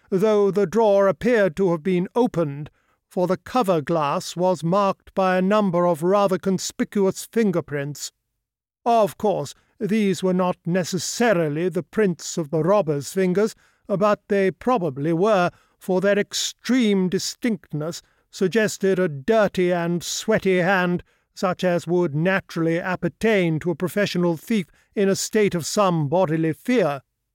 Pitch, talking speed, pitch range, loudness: 185 Hz, 140 wpm, 170-205 Hz, -22 LUFS